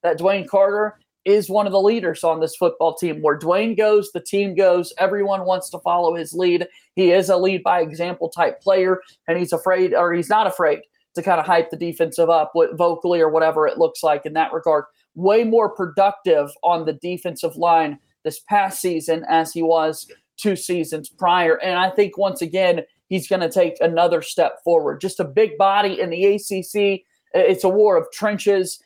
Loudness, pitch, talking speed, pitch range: -19 LUFS, 180 Hz, 200 wpm, 165-200 Hz